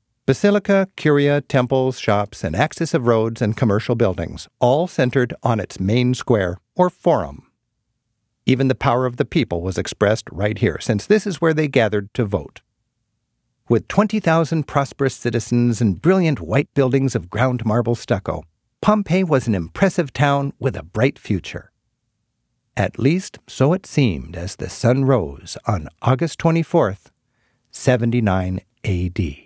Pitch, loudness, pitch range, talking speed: 125 Hz, -19 LUFS, 105-140 Hz, 145 wpm